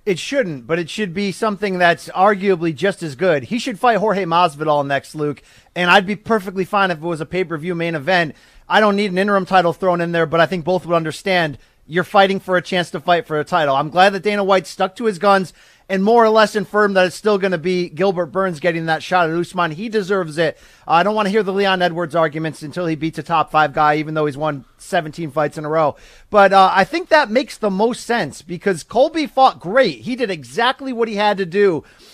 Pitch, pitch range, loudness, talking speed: 185 Hz, 165-205 Hz, -17 LUFS, 245 wpm